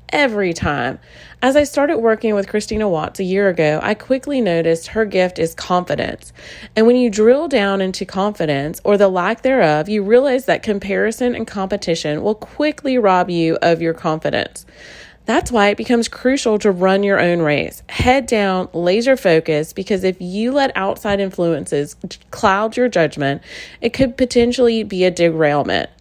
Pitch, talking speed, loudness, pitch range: 200 Hz, 165 wpm, -17 LUFS, 175-235 Hz